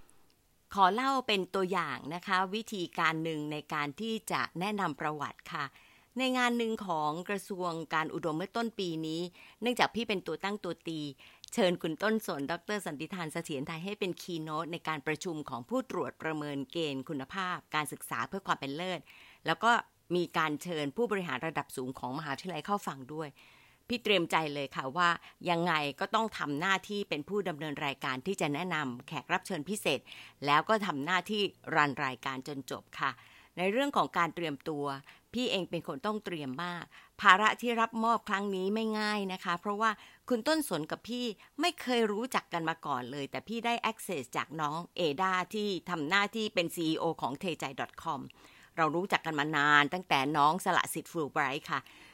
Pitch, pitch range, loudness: 170 Hz, 150-205 Hz, -33 LUFS